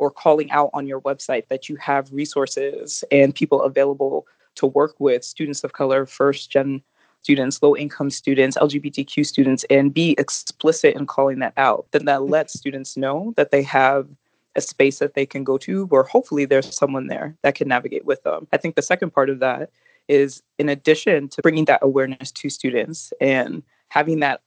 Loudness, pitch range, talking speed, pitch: -20 LUFS, 135-150 Hz, 190 wpm, 140 Hz